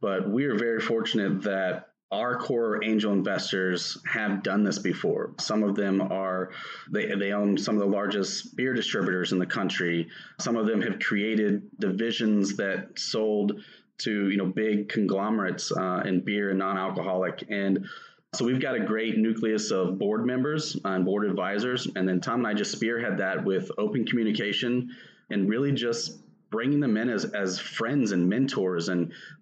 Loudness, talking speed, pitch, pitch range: -27 LUFS, 170 wpm, 100 Hz, 95-110 Hz